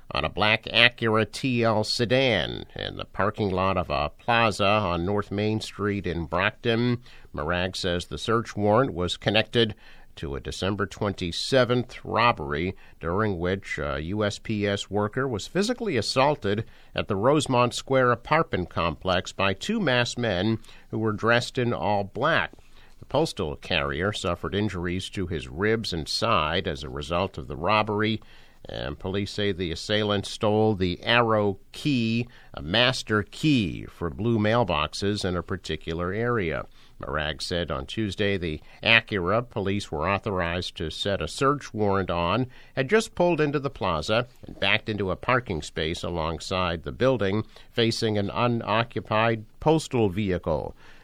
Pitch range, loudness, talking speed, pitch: 90-115 Hz, -25 LUFS, 145 wpm, 105 Hz